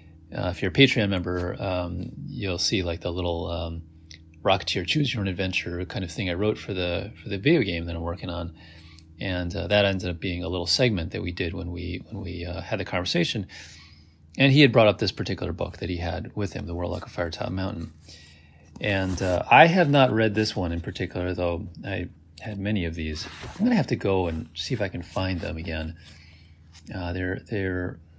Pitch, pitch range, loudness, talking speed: 90 Hz, 85-105 Hz, -25 LUFS, 220 wpm